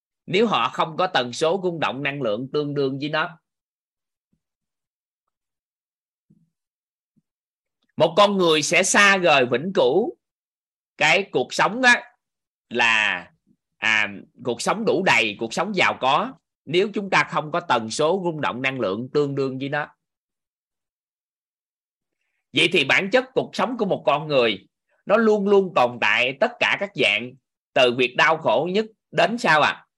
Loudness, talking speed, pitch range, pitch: -20 LUFS, 160 wpm, 140-200 Hz, 165 Hz